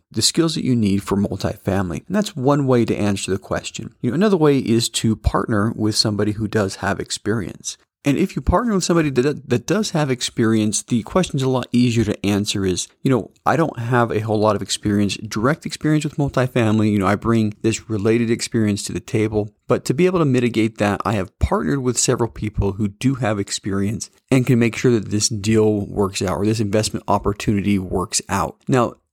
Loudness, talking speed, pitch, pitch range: -19 LUFS, 215 wpm, 110 Hz, 100-125 Hz